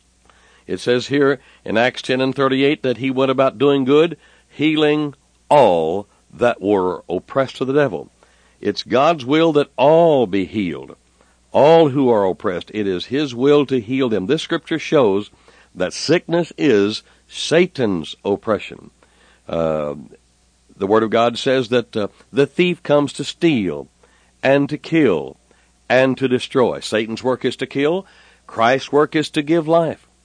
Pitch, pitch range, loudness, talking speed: 135 Hz, 110-150 Hz, -18 LUFS, 155 wpm